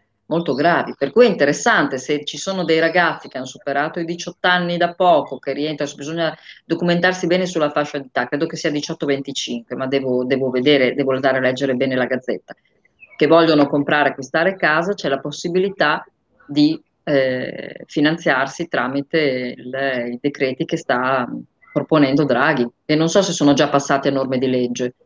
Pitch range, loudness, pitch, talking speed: 135-165 Hz, -18 LUFS, 145 Hz, 170 wpm